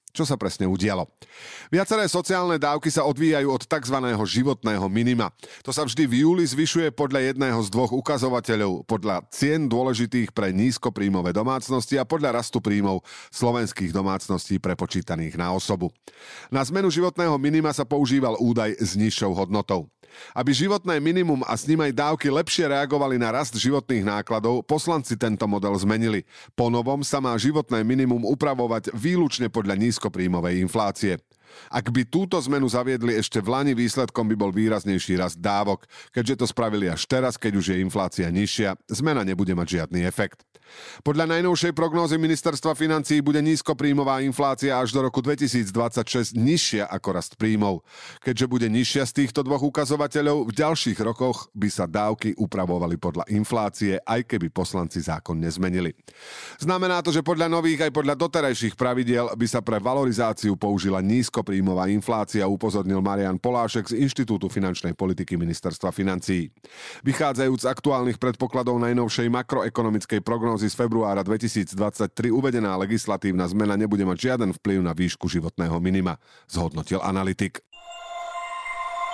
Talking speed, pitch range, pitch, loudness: 145 wpm, 100-140 Hz, 120 Hz, -24 LUFS